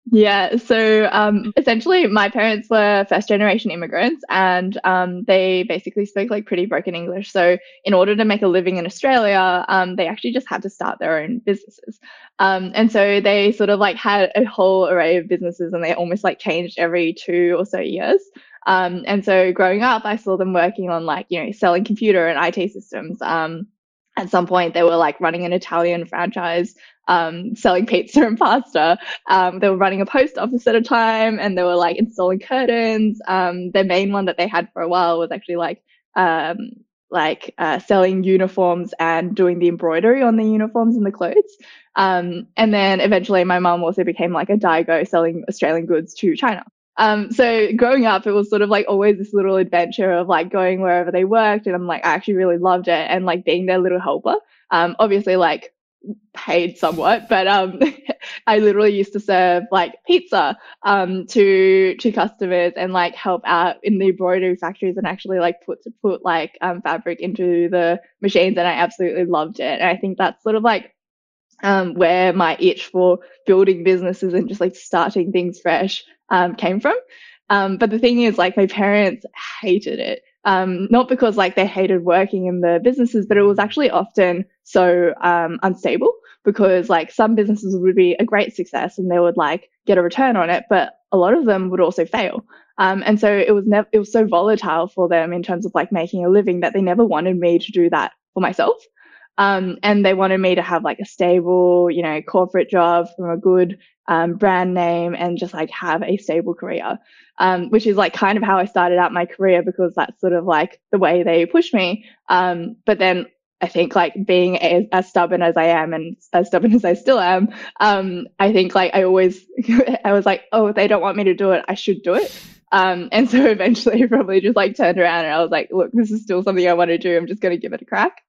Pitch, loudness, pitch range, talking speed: 185 Hz, -17 LUFS, 175-210 Hz, 215 wpm